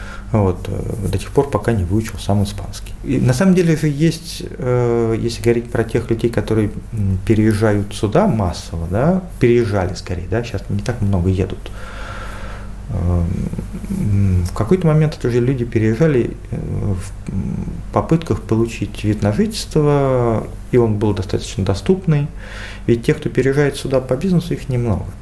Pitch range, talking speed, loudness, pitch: 100-125 Hz, 145 wpm, -18 LUFS, 110 Hz